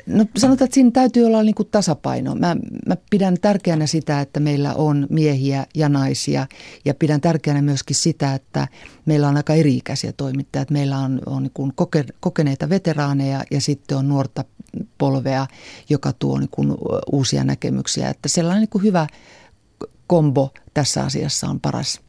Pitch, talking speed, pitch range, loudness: 145 Hz, 165 wpm, 135-170 Hz, -19 LUFS